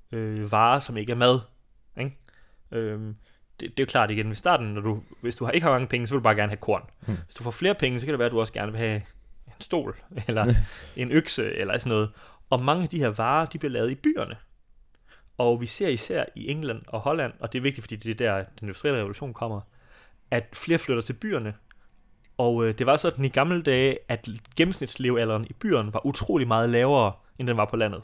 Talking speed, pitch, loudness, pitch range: 230 wpm, 115 Hz, -26 LUFS, 110-135 Hz